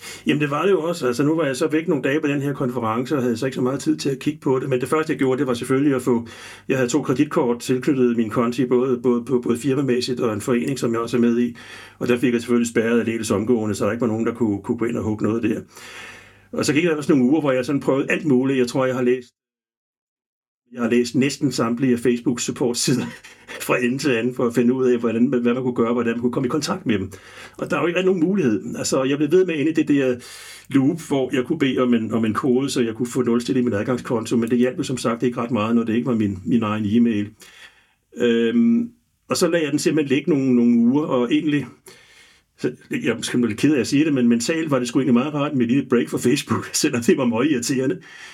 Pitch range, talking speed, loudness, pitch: 120-140 Hz, 280 wpm, -20 LUFS, 125 Hz